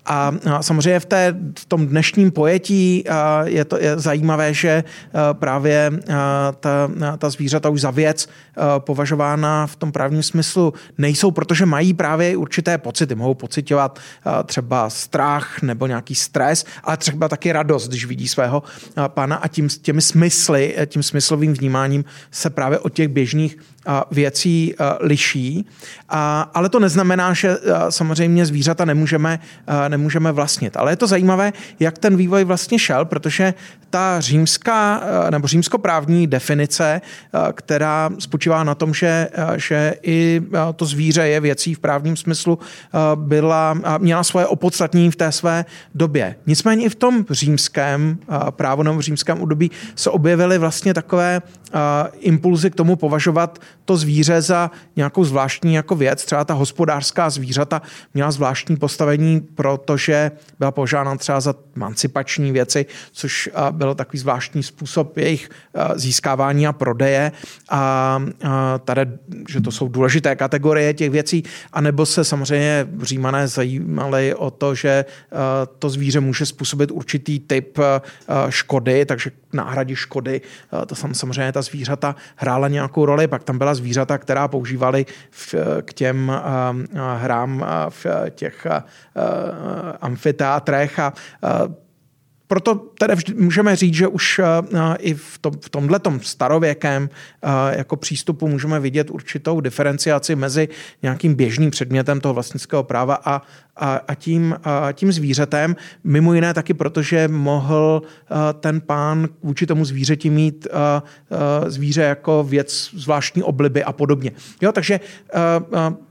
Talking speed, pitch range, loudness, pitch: 135 wpm, 140-165 Hz, -18 LUFS, 150 Hz